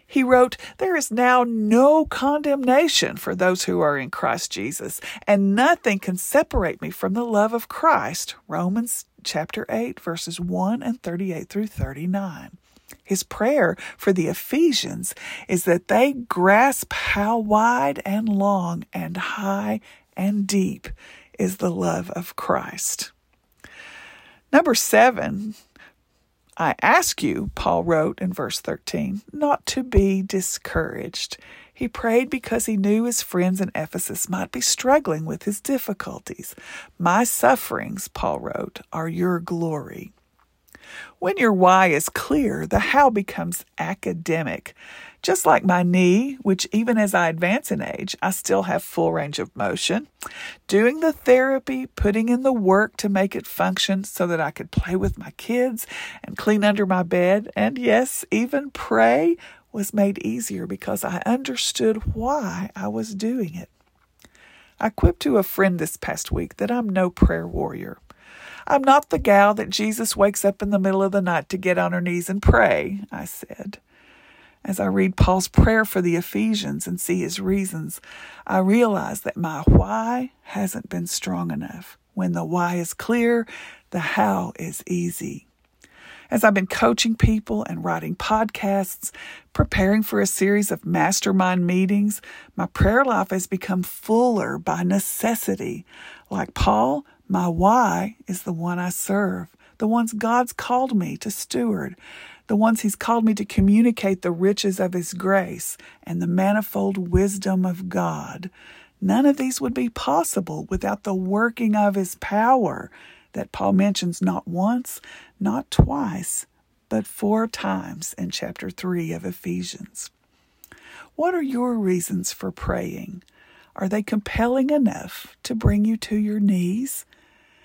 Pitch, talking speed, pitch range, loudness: 200 Hz, 150 wpm, 185-230 Hz, -22 LUFS